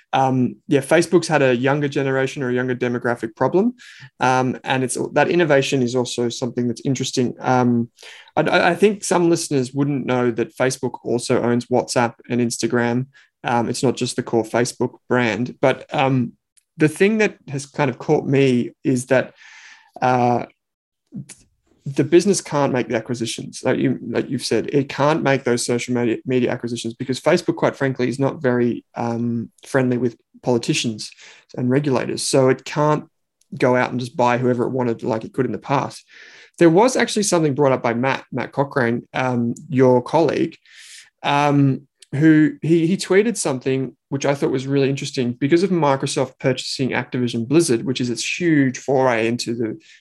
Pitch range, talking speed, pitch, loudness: 120-145 Hz, 180 wpm, 130 Hz, -19 LUFS